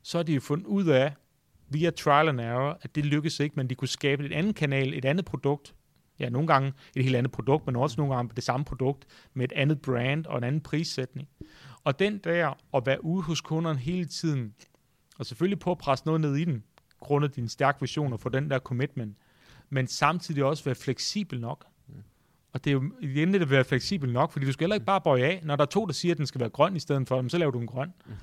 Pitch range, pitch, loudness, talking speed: 130-160 Hz, 140 Hz, -28 LUFS, 250 wpm